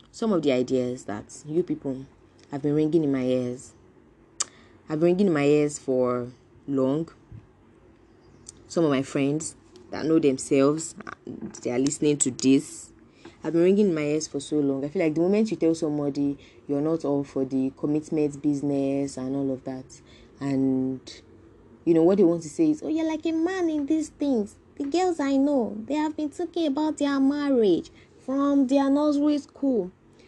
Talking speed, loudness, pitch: 185 wpm, -25 LUFS, 150 Hz